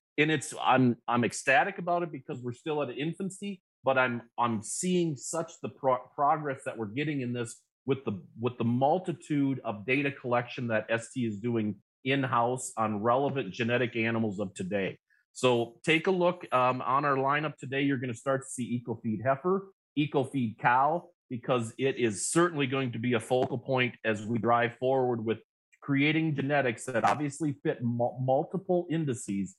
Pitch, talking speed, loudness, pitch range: 130 Hz, 175 wpm, -30 LUFS, 120-150 Hz